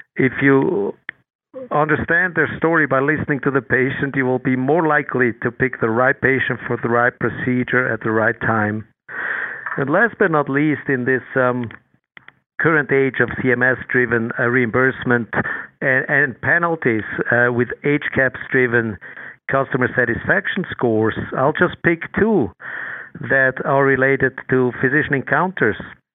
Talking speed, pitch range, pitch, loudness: 140 wpm, 120-140 Hz, 130 Hz, -18 LUFS